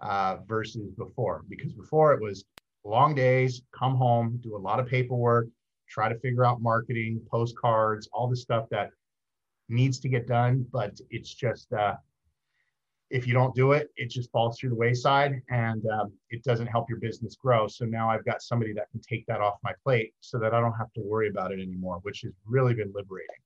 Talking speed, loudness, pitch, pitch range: 205 wpm, -28 LUFS, 115 Hz, 110-125 Hz